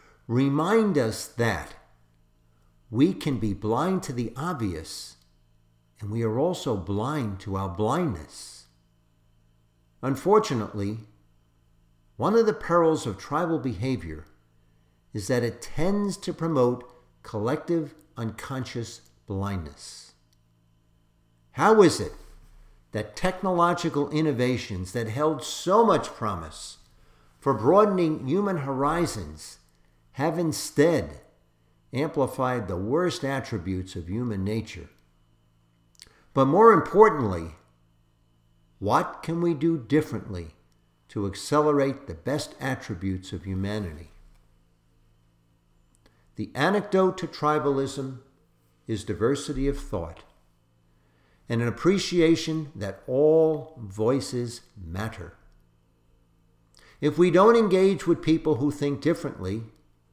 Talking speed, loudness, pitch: 100 wpm, -25 LUFS, 110 Hz